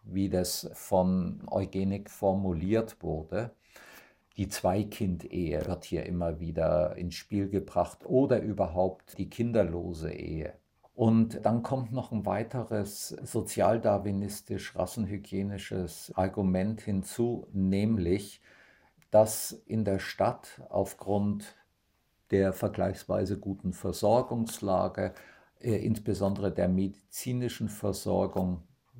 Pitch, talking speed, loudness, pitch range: 100 Hz, 90 wpm, -31 LUFS, 95-110 Hz